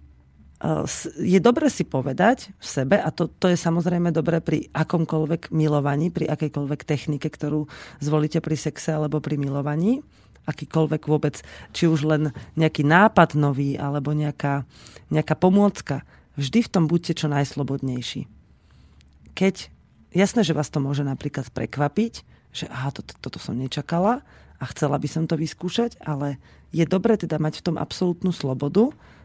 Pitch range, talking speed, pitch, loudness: 140-170 Hz, 150 wpm, 155 Hz, -23 LUFS